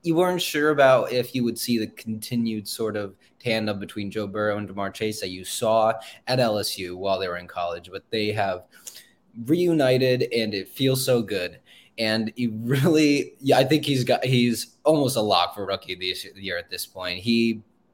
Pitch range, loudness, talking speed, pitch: 105-130 Hz, -24 LUFS, 195 wpm, 115 Hz